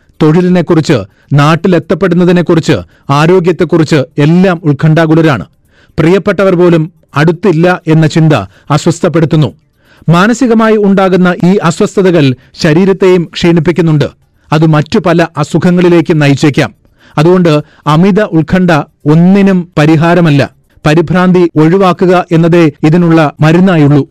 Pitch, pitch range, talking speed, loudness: 170 Hz, 155-180 Hz, 80 wpm, -7 LUFS